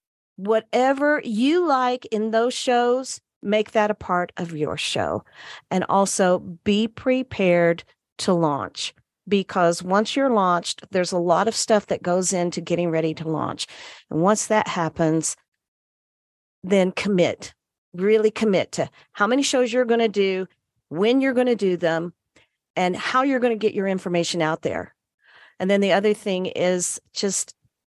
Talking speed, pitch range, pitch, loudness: 160 wpm, 175-225 Hz, 195 Hz, -22 LUFS